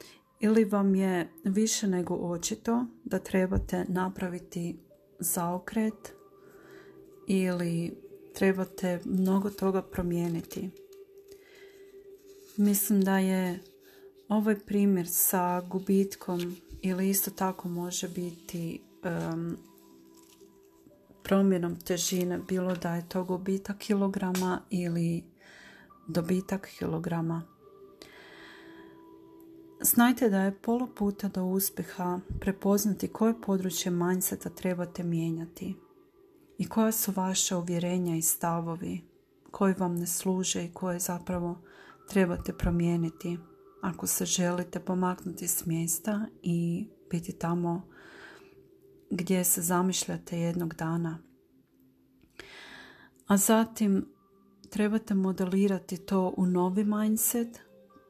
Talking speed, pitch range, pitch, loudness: 90 wpm, 175-215 Hz, 190 Hz, -30 LUFS